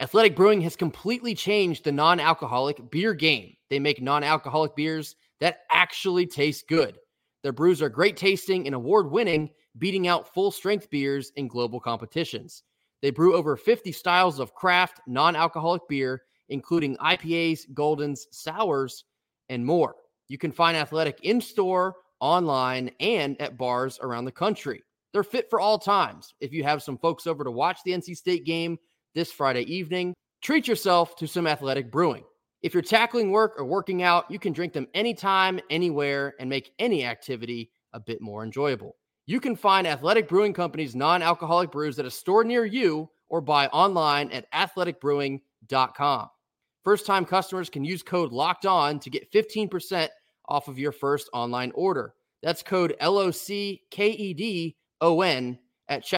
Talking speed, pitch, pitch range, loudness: 165 wpm, 165 Hz, 140-185 Hz, -25 LUFS